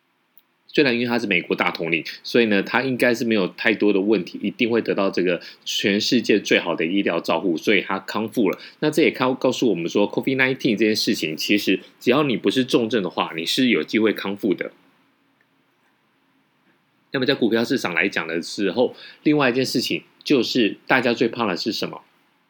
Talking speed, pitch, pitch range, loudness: 325 characters per minute, 120 Hz, 110-130 Hz, -21 LUFS